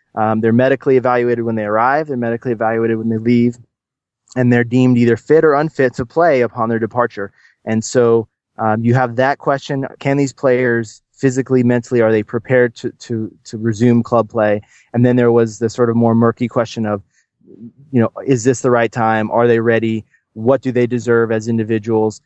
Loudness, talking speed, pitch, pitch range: -15 LUFS, 205 wpm, 120 Hz, 115-125 Hz